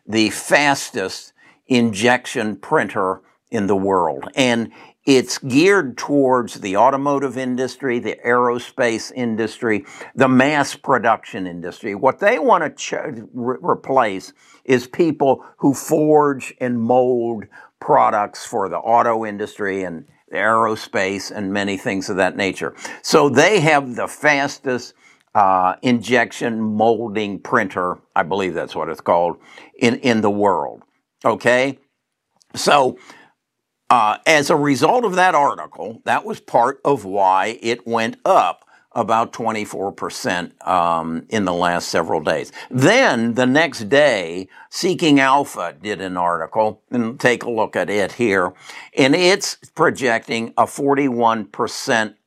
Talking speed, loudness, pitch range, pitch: 130 wpm, -18 LUFS, 105-130 Hz, 120 Hz